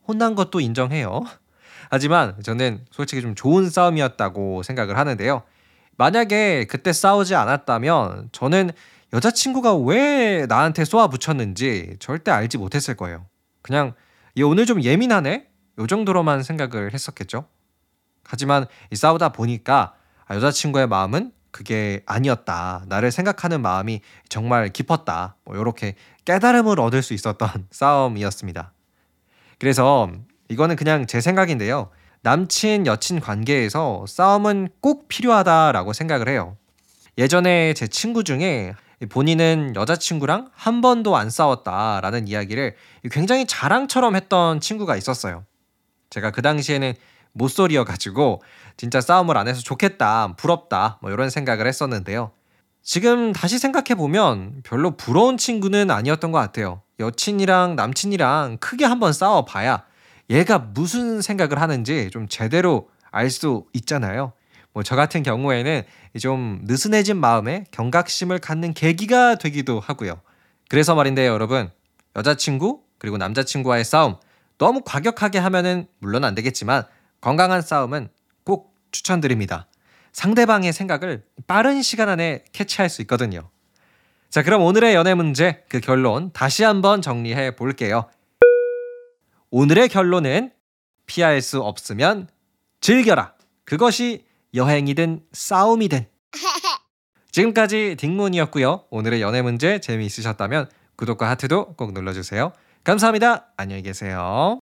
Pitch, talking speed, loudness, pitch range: 140 Hz, 305 characters per minute, -20 LUFS, 110-180 Hz